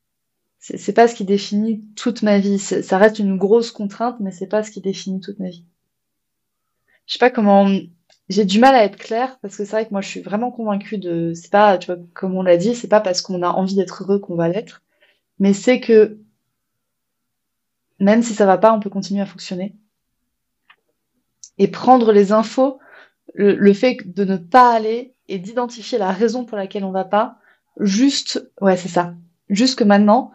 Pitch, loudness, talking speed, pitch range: 205 Hz, -17 LUFS, 205 wpm, 195-225 Hz